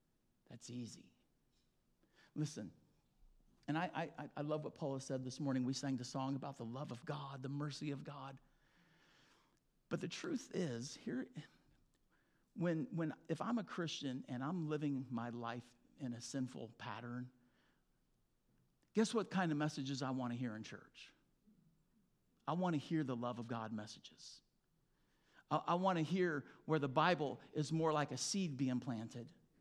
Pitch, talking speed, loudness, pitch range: 140 Hz, 165 wpm, -42 LUFS, 125-160 Hz